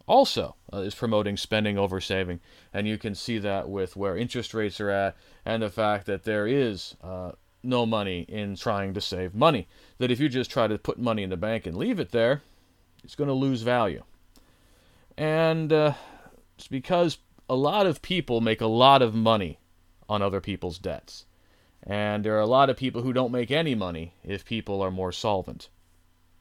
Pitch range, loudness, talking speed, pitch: 95-125 Hz, -26 LUFS, 195 wpm, 105 Hz